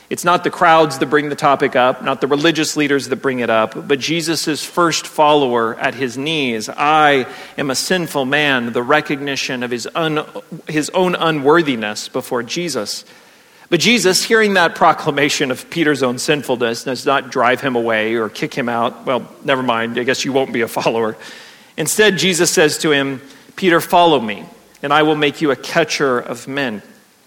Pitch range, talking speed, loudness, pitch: 130-160 Hz, 185 wpm, -16 LUFS, 145 Hz